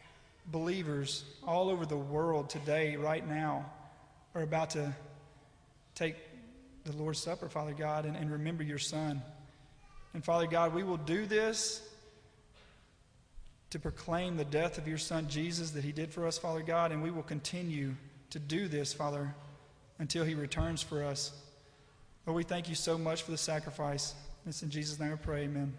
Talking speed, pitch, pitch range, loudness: 170 wpm, 155 Hz, 145-165 Hz, -36 LUFS